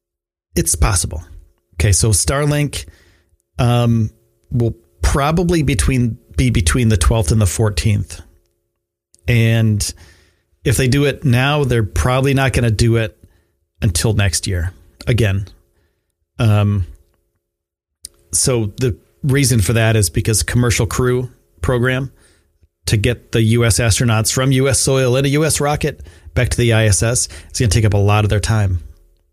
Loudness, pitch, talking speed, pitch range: -16 LUFS, 110 Hz, 145 wpm, 85-120 Hz